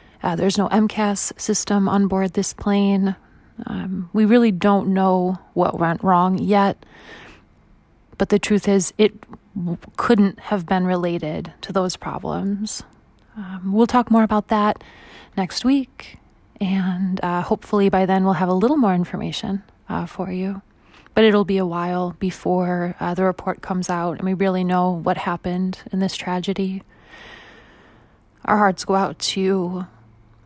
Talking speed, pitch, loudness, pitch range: 155 wpm, 190 Hz, -20 LUFS, 180-205 Hz